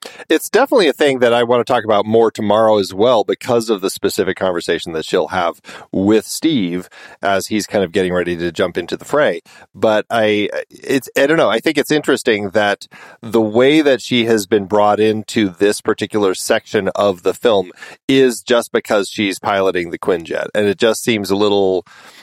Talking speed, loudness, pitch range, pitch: 195 wpm, -16 LUFS, 100-120 Hz, 110 Hz